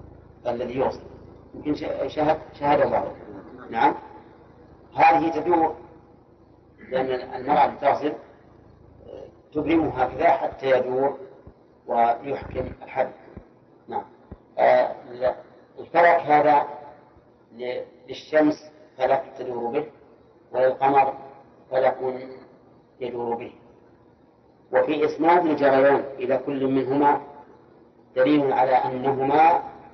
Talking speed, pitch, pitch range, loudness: 75 wpm, 135 Hz, 125-150 Hz, -23 LUFS